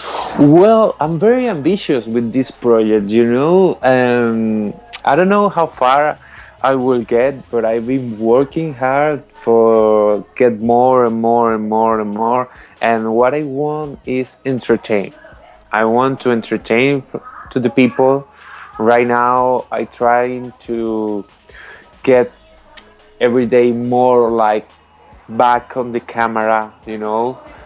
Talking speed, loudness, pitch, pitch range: 135 wpm, -14 LUFS, 120 Hz, 115-130 Hz